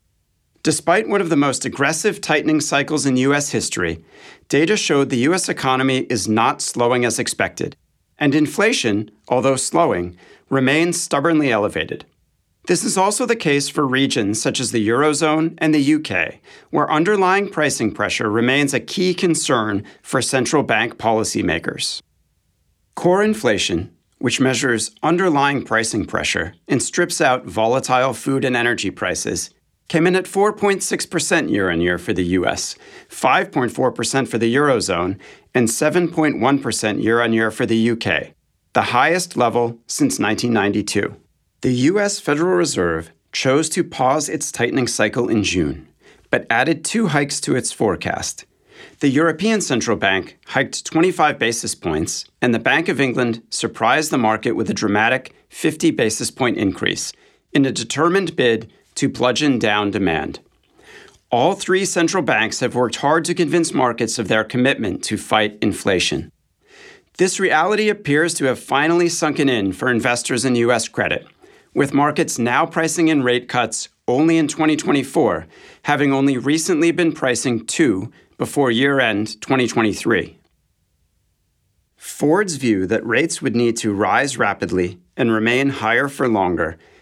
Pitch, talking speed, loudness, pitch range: 130 Hz, 145 wpm, -18 LUFS, 115-160 Hz